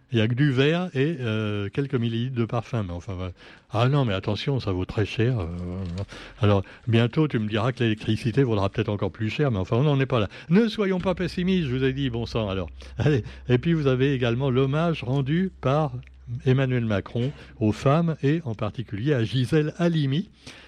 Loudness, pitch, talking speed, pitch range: -25 LUFS, 125 Hz, 210 wpm, 110-140 Hz